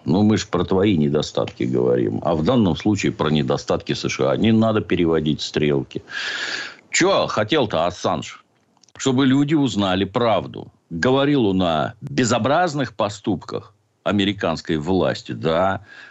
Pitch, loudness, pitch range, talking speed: 100 Hz, -20 LUFS, 80-125 Hz, 125 wpm